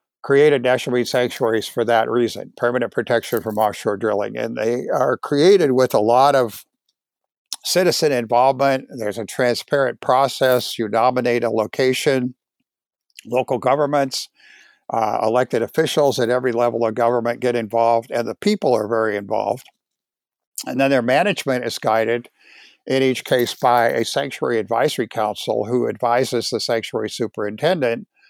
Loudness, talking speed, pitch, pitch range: -19 LUFS, 140 wpm, 125 Hz, 115-130 Hz